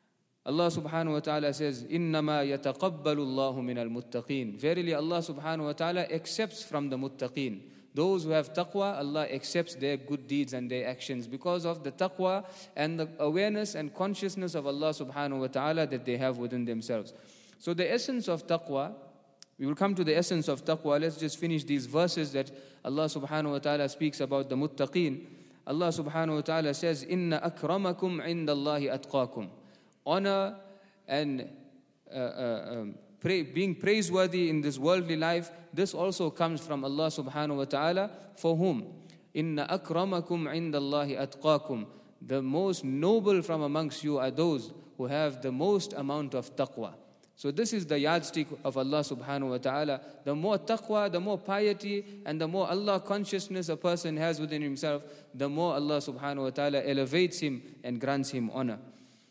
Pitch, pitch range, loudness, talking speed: 155 Hz, 140-175 Hz, -31 LUFS, 165 wpm